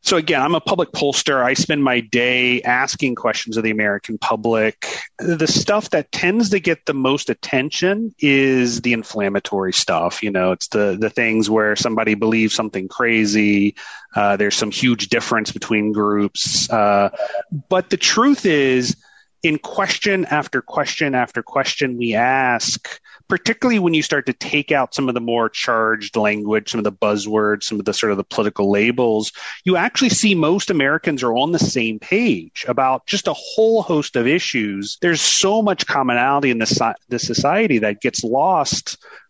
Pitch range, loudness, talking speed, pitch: 110-160 Hz, -18 LUFS, 170 wpm, 125 Hz